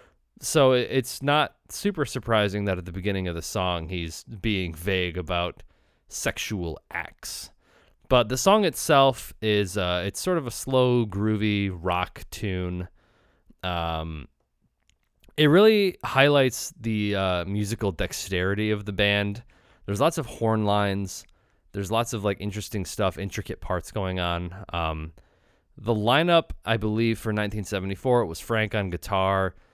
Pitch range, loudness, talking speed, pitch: 90-115 Hz, -25 LUFS, 140 wpm, 105 Hz